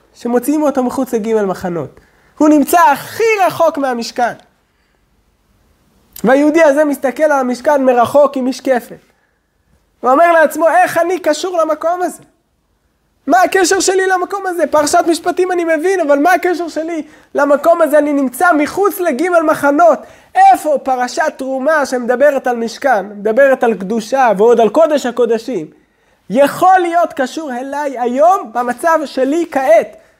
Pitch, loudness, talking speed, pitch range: 300 Hz, -13 LUFS, 135 wpm, 255-335 Hz